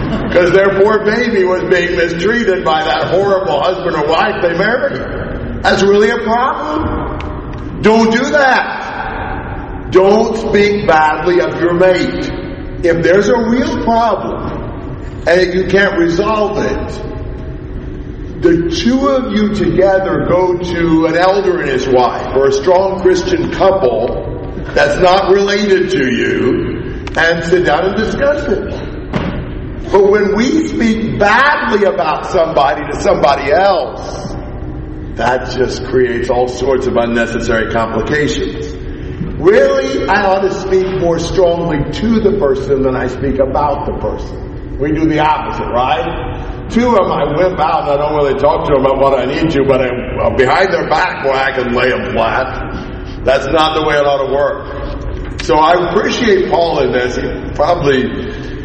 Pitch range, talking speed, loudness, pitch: 140-200 Hz, 155 wpm, -13 LUFS, 180 Hz